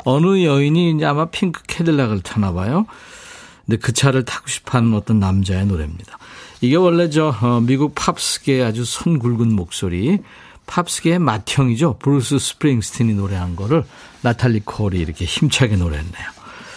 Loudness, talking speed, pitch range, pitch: -18 LUFS, 345 characters per minute, 105-160 Hz, 125 Hz